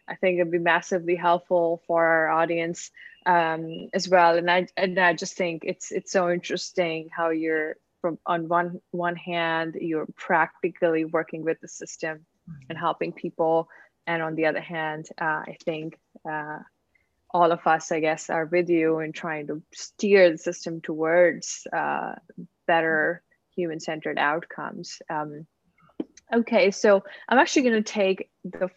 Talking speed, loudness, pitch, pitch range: 155 wpm, -25 LUFS, 170 Hz, 160-180 Hz